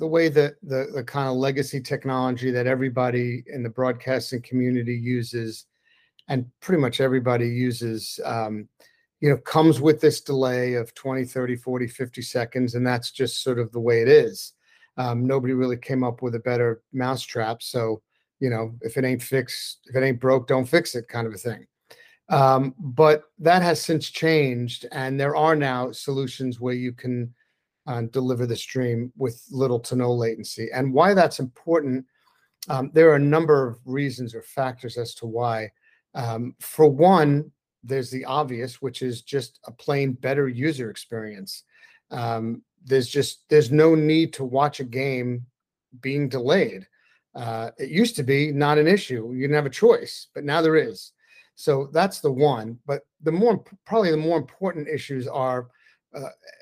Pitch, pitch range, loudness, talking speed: 130 Hz, 125-150 Hz, -23 LUFS, 175 wpm